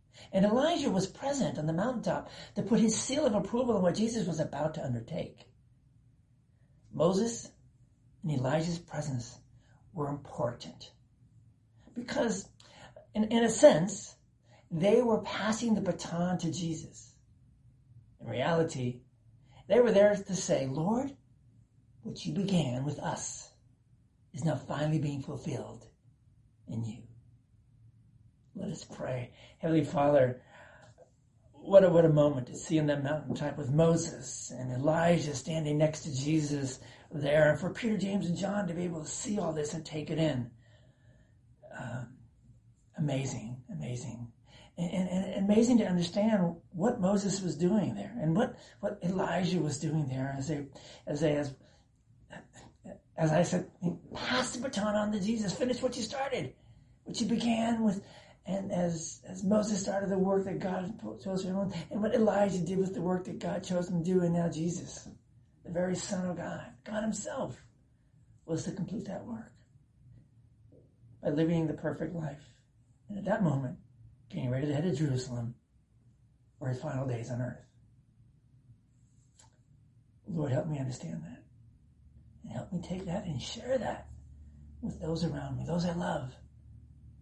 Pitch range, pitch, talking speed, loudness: 125-185 Hz, 150 Hz, 155 wpm, -32 LUFS